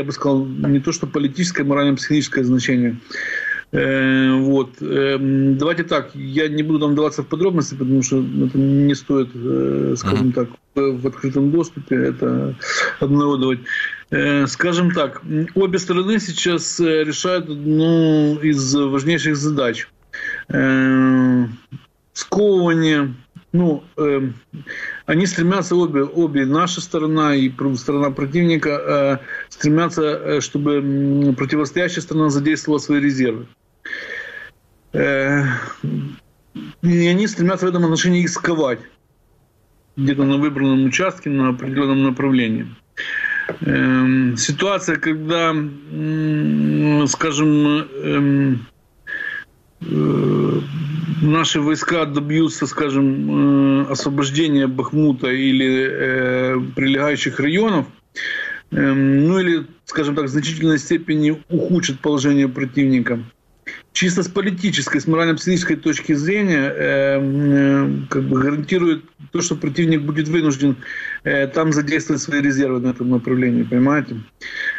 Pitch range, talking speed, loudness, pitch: 135-165 Hz, 100 wpm, -18 LUFS, 145 Hz